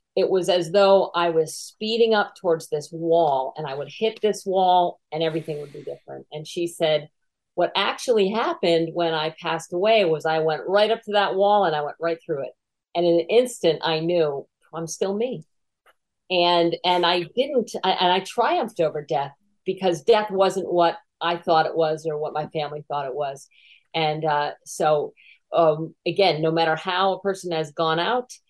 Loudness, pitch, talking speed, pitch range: -22 LUFS, 170 Hz, 195 wpm, 160-195 Hz